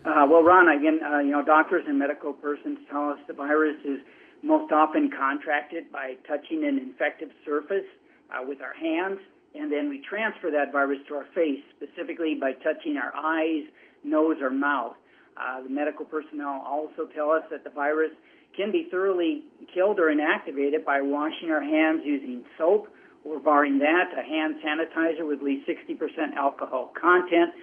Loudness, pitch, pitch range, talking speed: -25 LUFS, 155 Hz, 145-215 Hz, 170 wpm